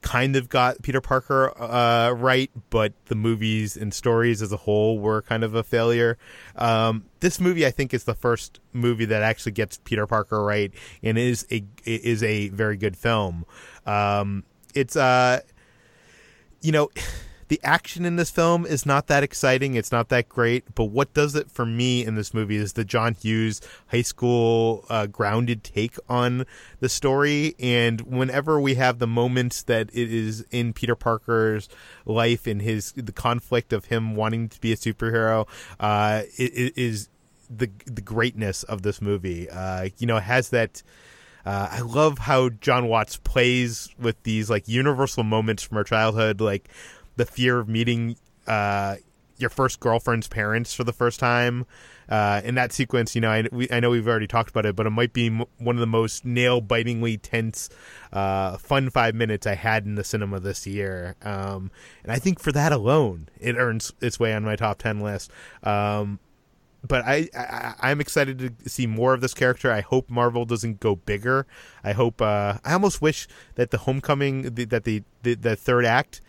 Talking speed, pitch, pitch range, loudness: 185 wpm, 115 Hz, 110-125 Hz, -23 LUFS